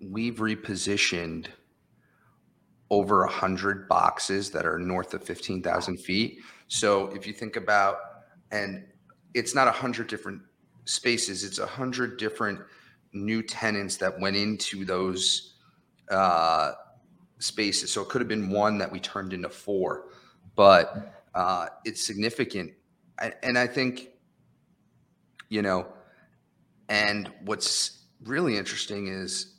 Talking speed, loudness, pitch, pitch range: 125 wpm, -27 LUFS, 100 Hz, 95-110 Hz